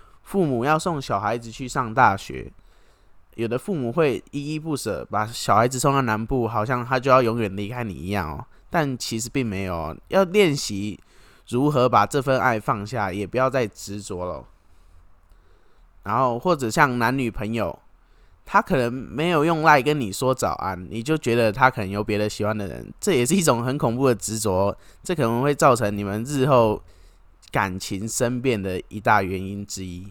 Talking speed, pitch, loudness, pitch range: 270 characters per minute, 115 Hz, -22 LUFS, 100-130 Hz